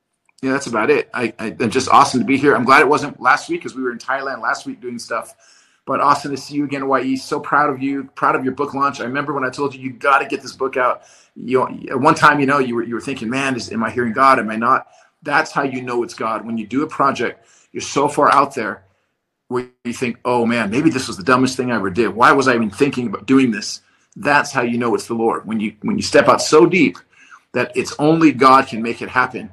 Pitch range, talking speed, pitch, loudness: 120-140 Hz, 275 wpm, 130 Hz, -17 LUFS